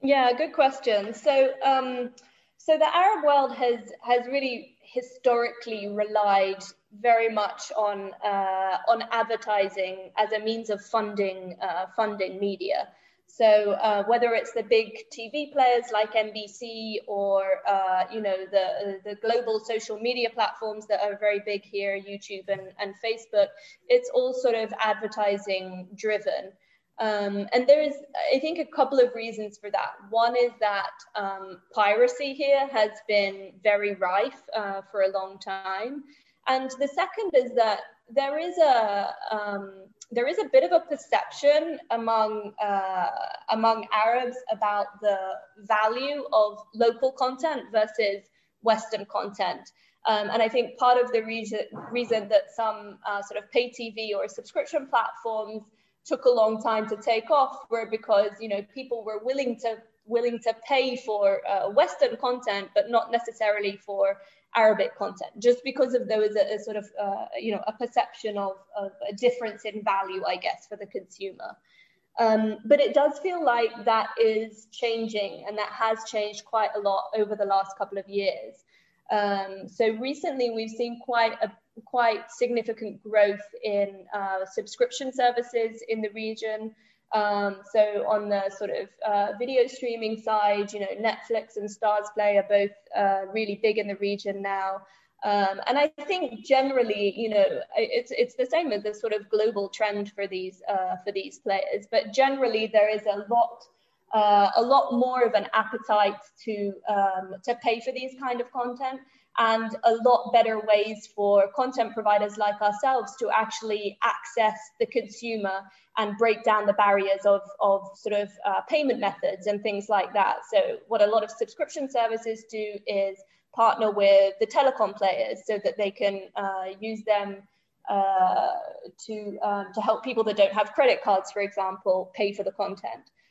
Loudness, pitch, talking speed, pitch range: -26 LUFS, 220 Hz, 165 wpm, 205-245 Hz